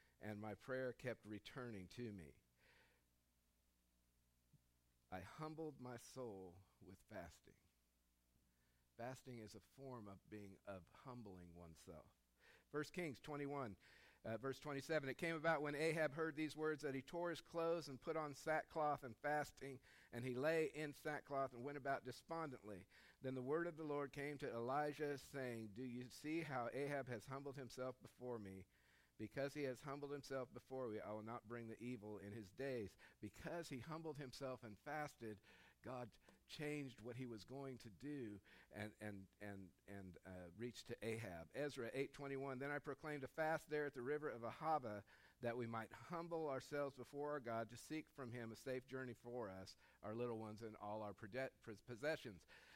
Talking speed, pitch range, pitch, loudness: 175 wpm, 105-145 Hz, 125 Hz, -50 LUFS